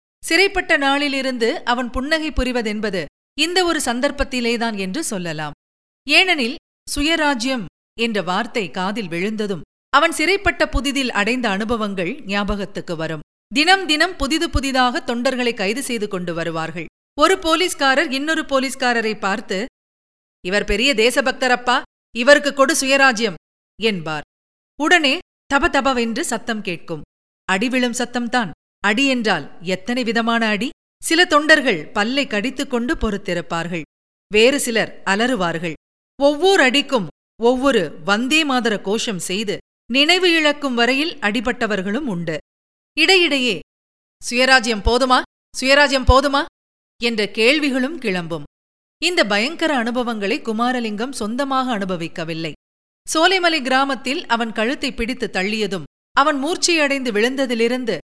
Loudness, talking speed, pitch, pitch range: -18 LUFS, 100 wpm, 245 Hz, 205-280 Hz